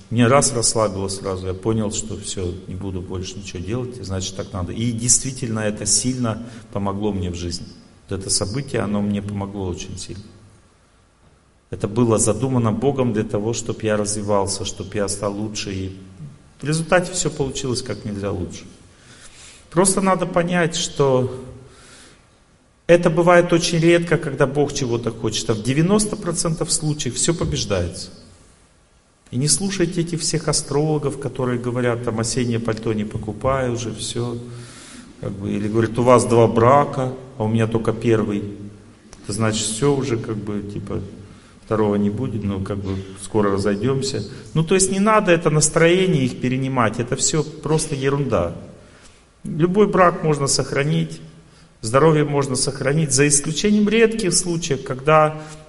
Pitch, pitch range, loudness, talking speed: 120 Hz, 105-145 Hz, -20 LUFS, 150 wpm